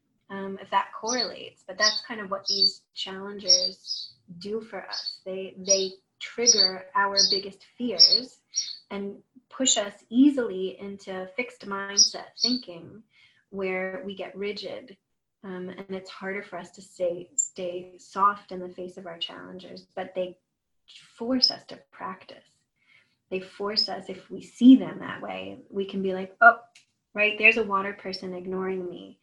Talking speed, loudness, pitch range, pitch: 155 wpm, -24 LUFS, 185-210 Hz, 195 Hz